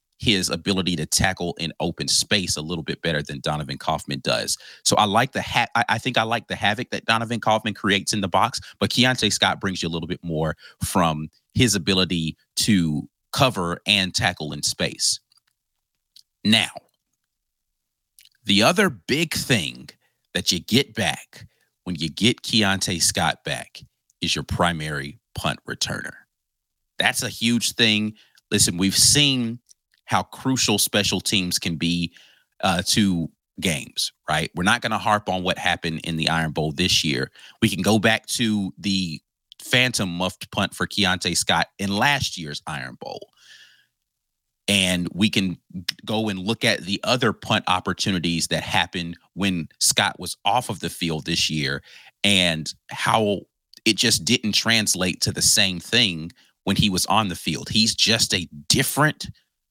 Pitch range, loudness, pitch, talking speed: 85-110 Hz, -21 LUFS, 95 Hz, 160 wpm